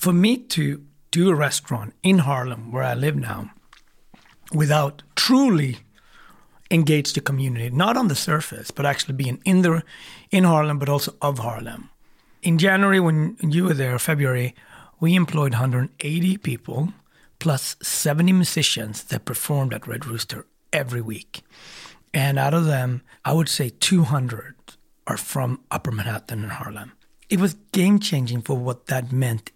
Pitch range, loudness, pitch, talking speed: 125-165 Hz, -22 LUFS, 145 Hz, 150 wpm